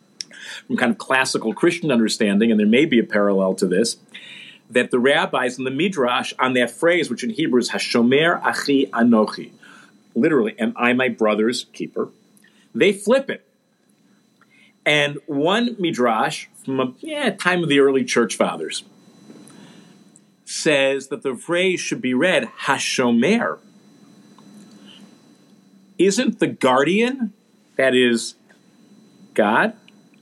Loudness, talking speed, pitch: -19 LUFS, 130 wpm, 150 Hz